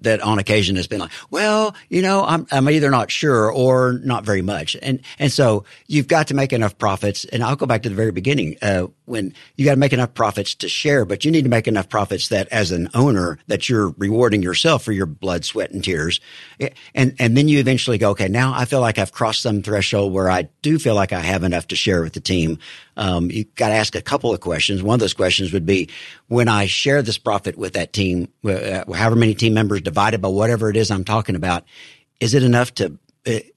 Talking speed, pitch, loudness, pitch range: 240 wpm, 110 Hz, -18 LUFS, 95-130 Hz